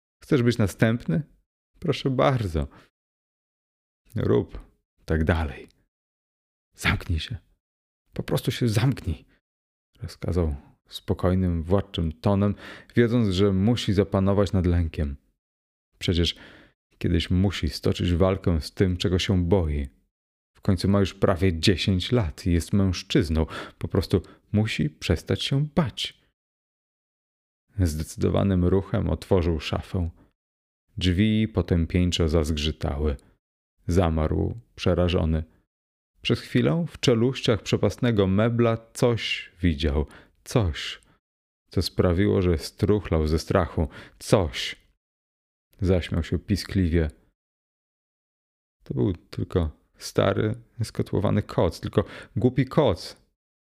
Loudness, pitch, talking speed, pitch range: -25 LUFS, 95 Hz, 95 wpm, 80-105 Hz